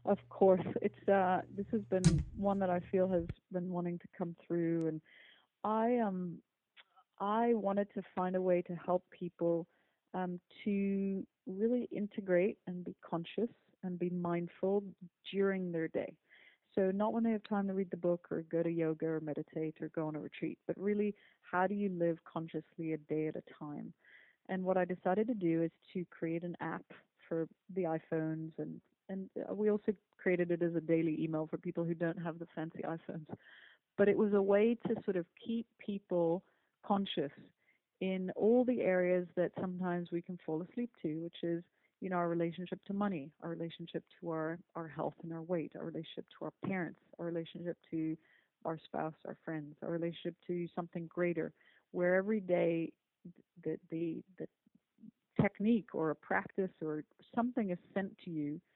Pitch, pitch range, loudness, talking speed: 180 Hz, 165-200 Hz, -37 LUFS, 185 wpm